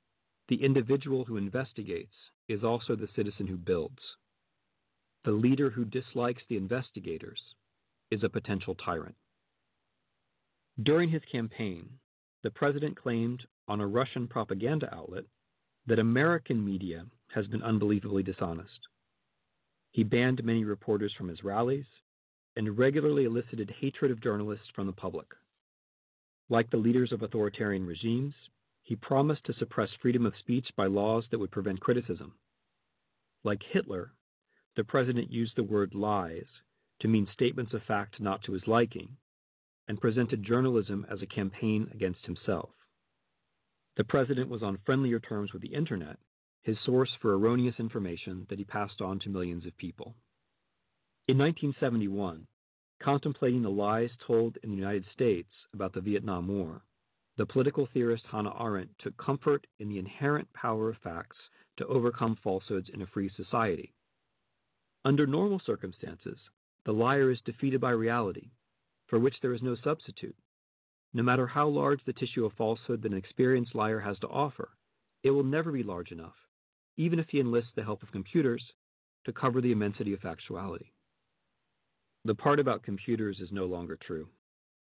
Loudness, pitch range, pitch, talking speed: -31 LUFS, 100-125 Hz, 115 Hz, 150 wpm